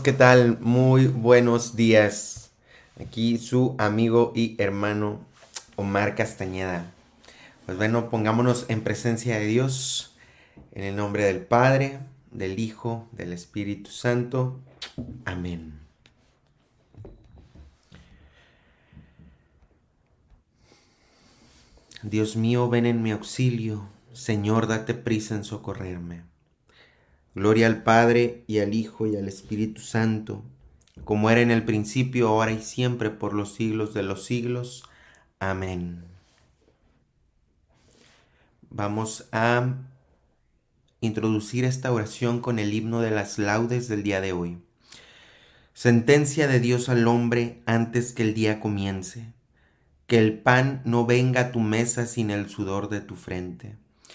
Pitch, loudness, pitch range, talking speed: 110 Hz, -24 LUFS, 100-120 Hz, 115 wpm